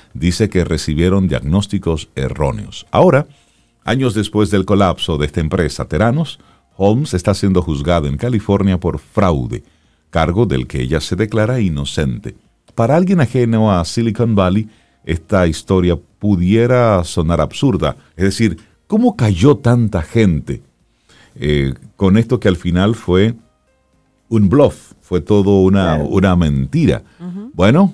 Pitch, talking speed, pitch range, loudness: 95 Hz, 130 wpm, 85-115 Hz, -15 LUFS